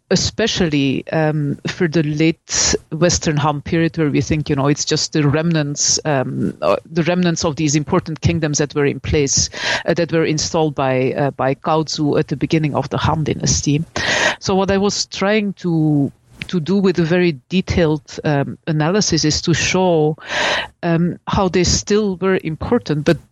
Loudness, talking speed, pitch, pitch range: -17 LUFS, 170 wpm, 155 Hz, 150-175 Hz